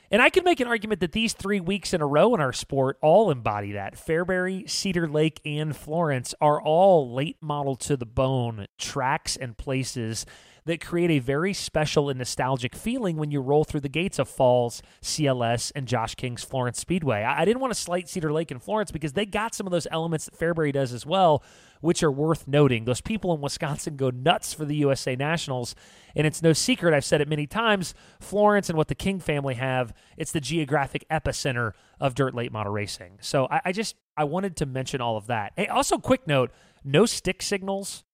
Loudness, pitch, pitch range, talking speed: -25 LUFS, 150 Hz, 130-175 Hz, 210 wpm